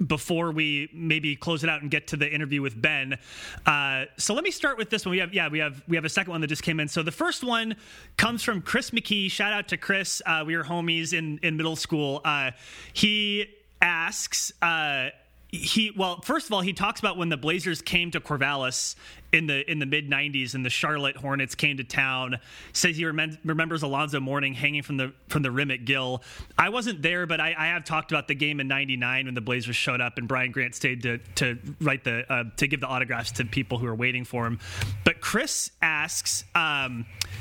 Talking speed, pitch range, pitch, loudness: 230 wpm, 130-170 Hz, 150 Hz, -26 LUFS